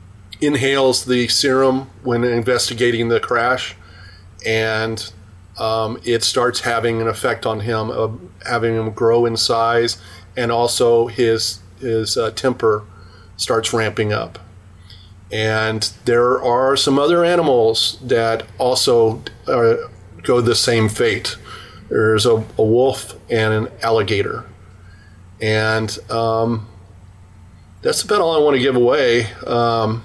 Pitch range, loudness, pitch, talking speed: 100-120 Hz, -17 LUFS, 110 Hz, 125 wpm